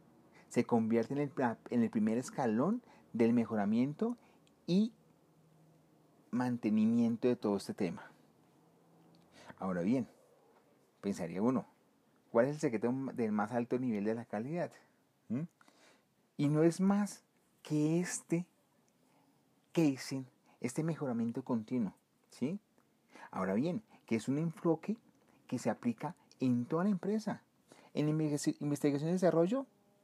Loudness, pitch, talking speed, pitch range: -35 LUFS, 155 Hz, 120 wpm, 120-205 Hz